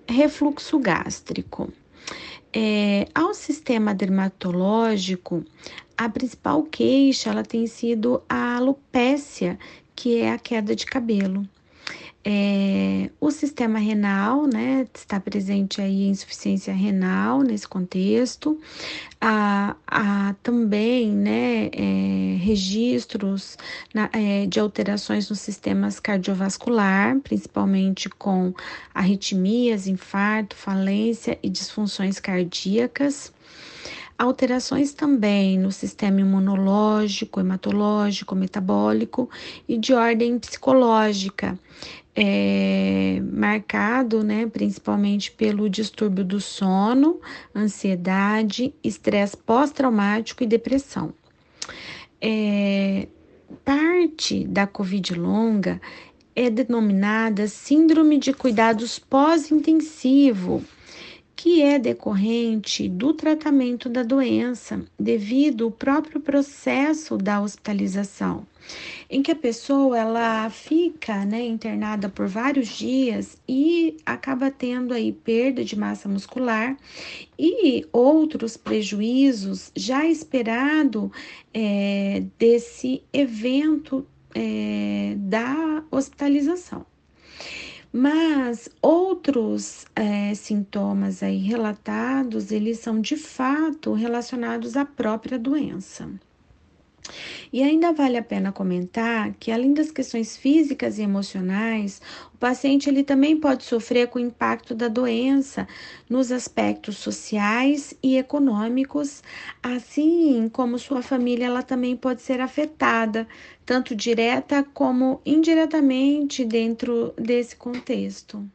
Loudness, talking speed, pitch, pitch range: -22 LUFS, 95 wpm, 230 Hz, 205-270 Hz